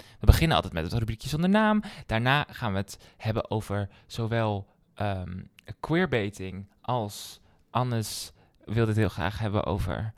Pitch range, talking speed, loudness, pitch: 95-115 Hz, 145 wpm, -28 LUFS, 105 Hz